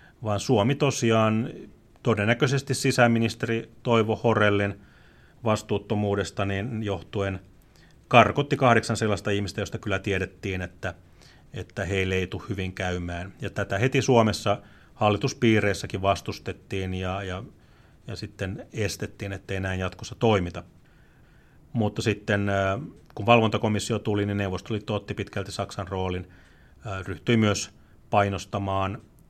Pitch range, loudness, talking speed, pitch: 95-115 Hz, -26 LUFS, 110 wpm, 100 Hz